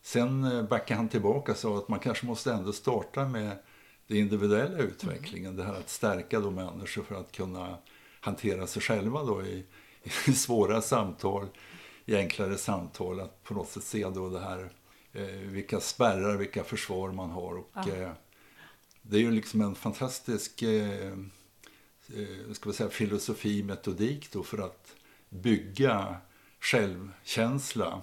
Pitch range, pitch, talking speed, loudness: 95-115 Hz, 100 Hz, 130 wpm, -32 LUFS